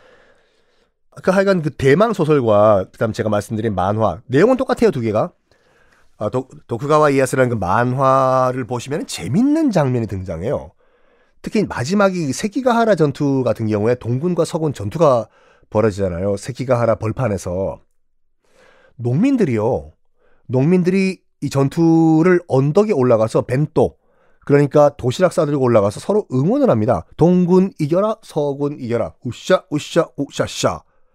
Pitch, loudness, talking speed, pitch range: 140 Hz, -17 LUFS, 315 characters per minute, 120-180 Hz